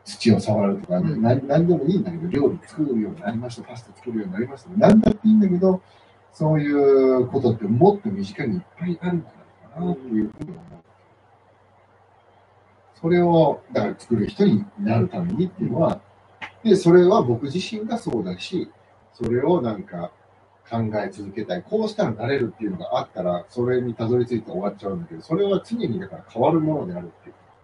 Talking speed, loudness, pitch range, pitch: 400 characters per minute, -22 LUFS, 110-180 Hz, 140 Hz